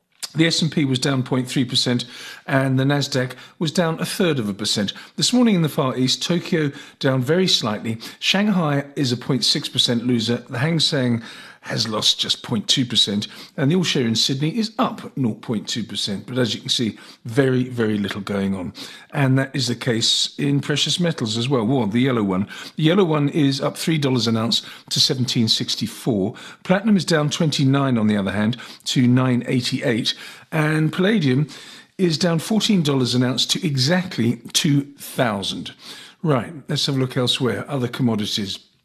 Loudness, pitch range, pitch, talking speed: -20 LUFS, 120-160 Hz, 135 Hz, 175 wpm